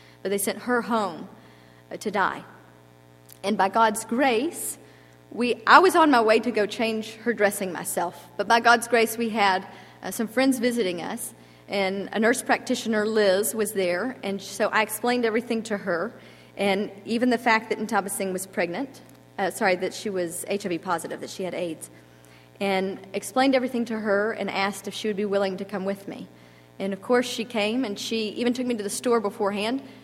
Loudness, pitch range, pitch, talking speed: -24 LUFS, 190-230 Hz, 205 Hz, 200 wpm